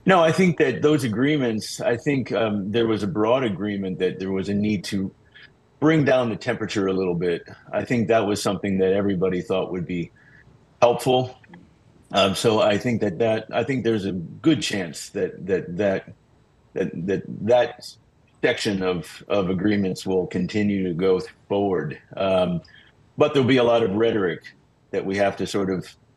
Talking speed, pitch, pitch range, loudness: 180 wpm, 105 Hz, 95-120 Hz, -23 LUFS